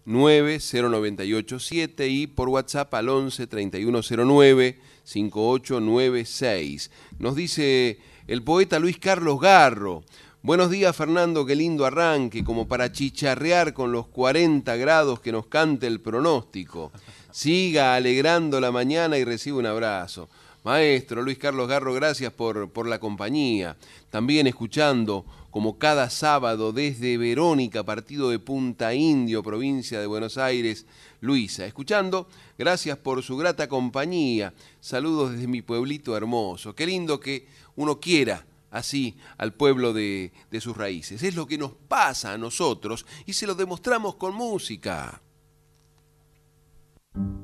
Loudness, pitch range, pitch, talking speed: -24 LUFS, 115-150 Hz, 130 Hz, 130 wpm